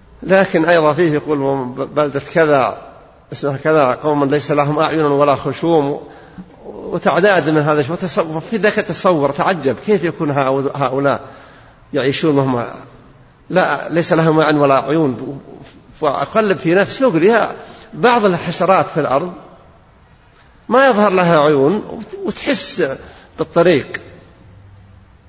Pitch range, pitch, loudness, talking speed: 140-180 Hz, 155 Hz, -15 LUFS, 115 wpm